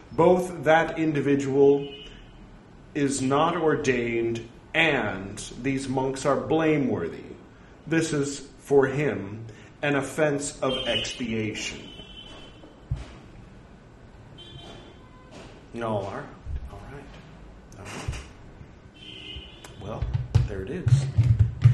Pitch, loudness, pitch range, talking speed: 135 Hz, -25 LUFS, 115-145 Hz, 85 wpm